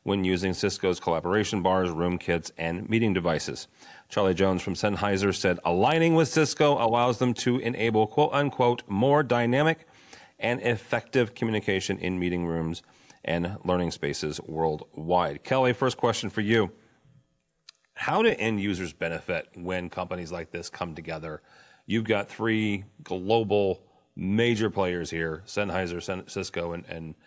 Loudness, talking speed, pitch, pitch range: -27 LUFS, 140 wpm, 100 Hz, 90-120 Hz